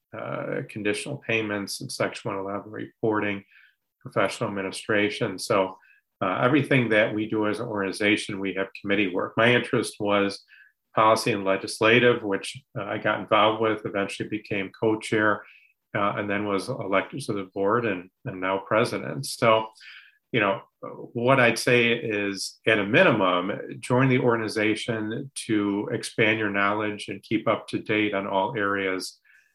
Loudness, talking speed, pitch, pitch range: -25 LUFS, 150 wpm, 105 Hz, 100-115 Hz